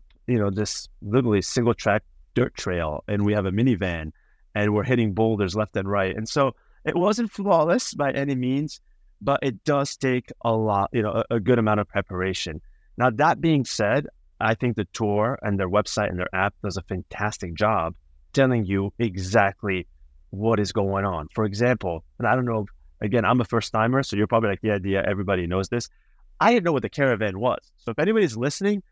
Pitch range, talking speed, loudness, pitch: 100-125 Hz, 210 wpm, -24 LUFS, 105 Hz